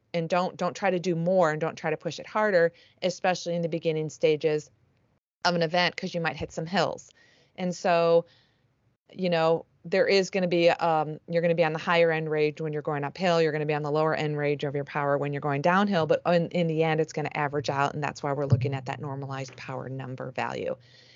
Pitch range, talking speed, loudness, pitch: 145-170 Hz, 250 wpm, -27 LUFS, 160 Hz